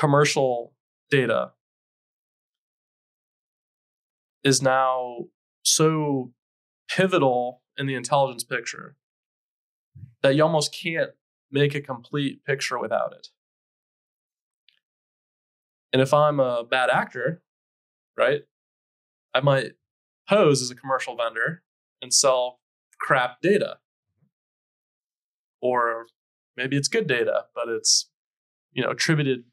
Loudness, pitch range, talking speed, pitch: -23 LUFS, 120-145 Hz, 100 wpm, 130 Hz